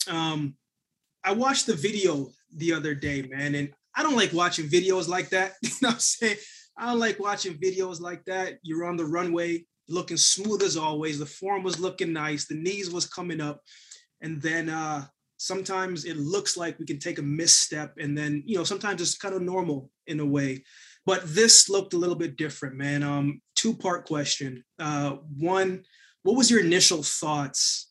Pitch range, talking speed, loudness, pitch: 150-190 Hz, 195 wpm, -25 LUFS, 170 Hz